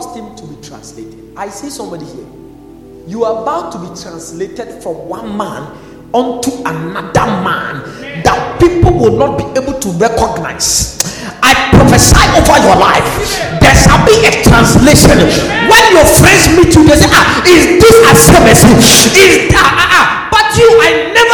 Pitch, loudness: 295 Hz, -6 LUFS